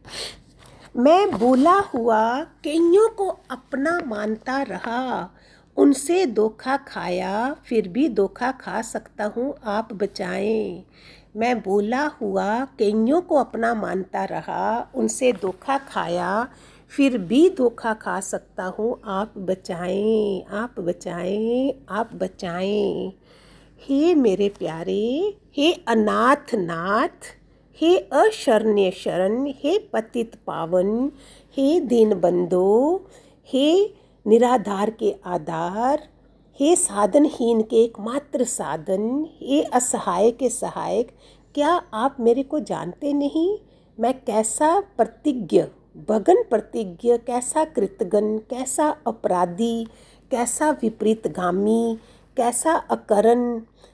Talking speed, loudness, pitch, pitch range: 100 wpm, -22 LUFS, 230 Hz, 205-275 Hz